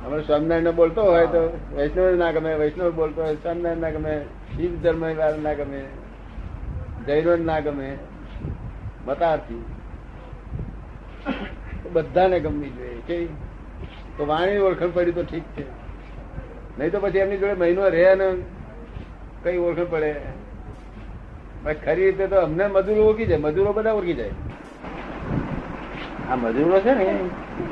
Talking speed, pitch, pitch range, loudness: 130 wpm, 165 Hz, 150-180 Hz, -22 LUFS